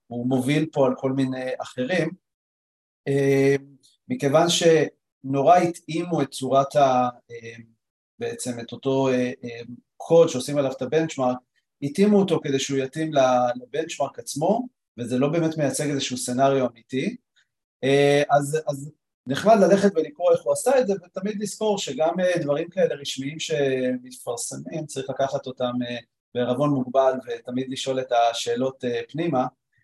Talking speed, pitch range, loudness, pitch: 125 wpm, 125-155 Hz, -23 LUFS, 135 Hz